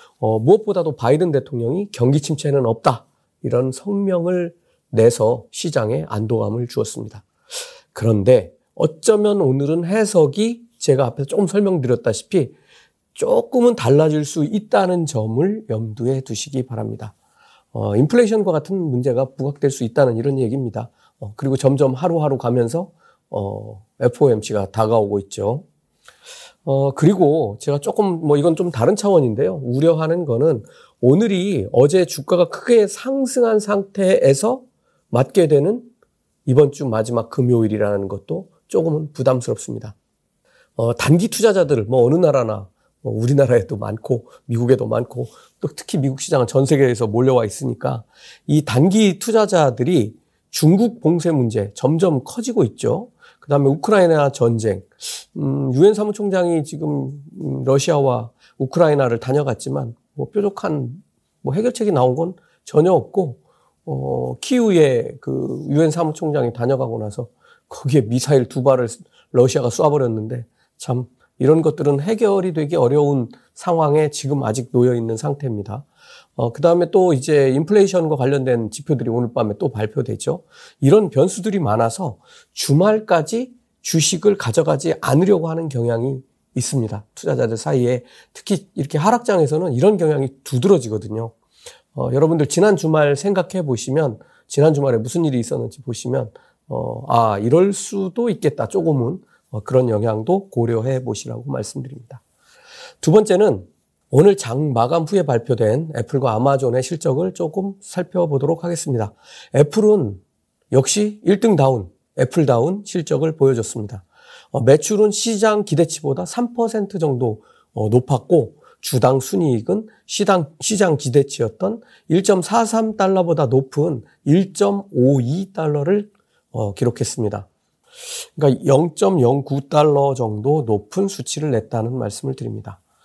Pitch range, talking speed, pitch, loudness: 125-180 Hz, 305 characters per minute, 145 Hz, -18 LUFS